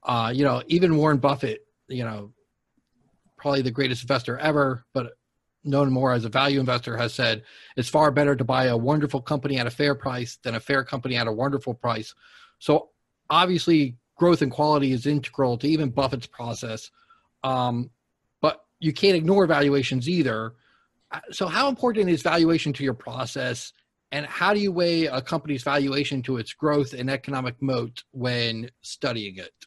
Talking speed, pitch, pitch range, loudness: 170 wpm, 135 Hz, 125-150 Hz, -24 LUFS